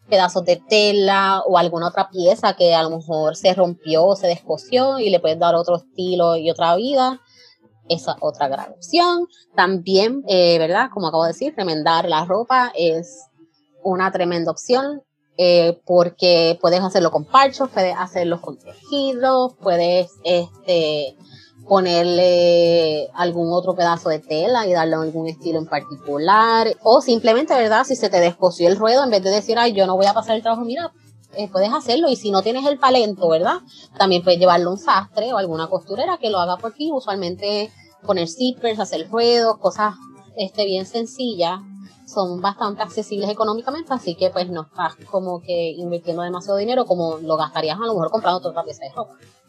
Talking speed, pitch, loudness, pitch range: 180 wpm, 185 Hz, -18 LUFS, 170-220 Hz